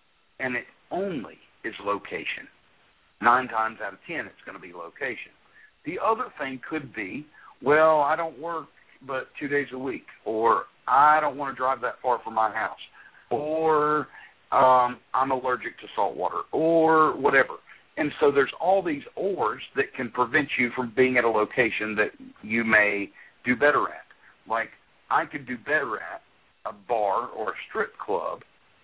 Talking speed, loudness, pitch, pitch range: 170 wpm, -25 LUFS, 135 Hz, 125-155 Hz